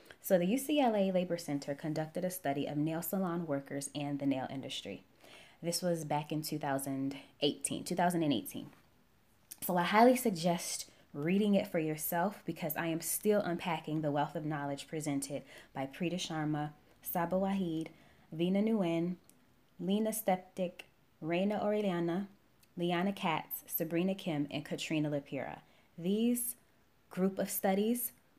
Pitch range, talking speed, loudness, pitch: 150-190 Hz, 130 wpm, -35 LUFS, 170 Hz